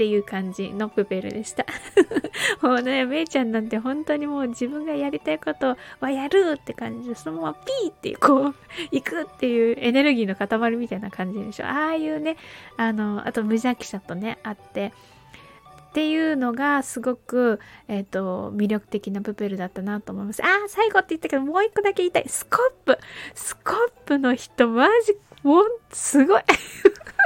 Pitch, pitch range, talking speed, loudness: 250 Hz, 215-315 Hz, 360 characters per minute, -23 LUFS